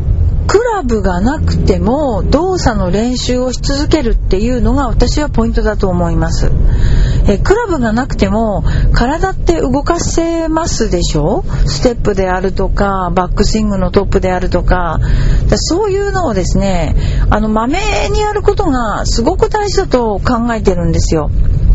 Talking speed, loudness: 315 characters per minute, -13 LUFS